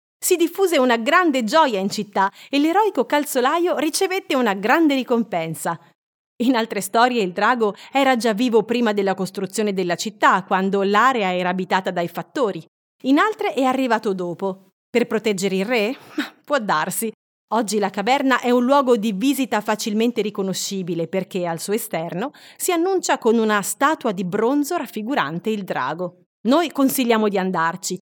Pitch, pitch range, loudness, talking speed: 220 Hz, 190-265 Hz, -20 LUFS, 155 wpm